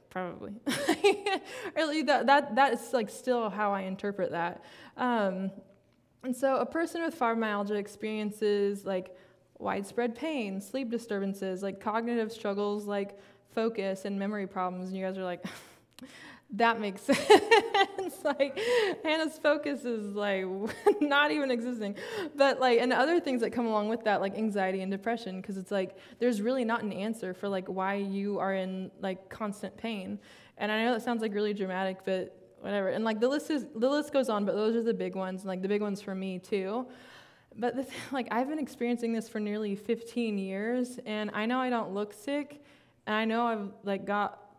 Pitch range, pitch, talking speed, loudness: 200-255 Hz, 220 Hz, 185 wpm, -31 LUFS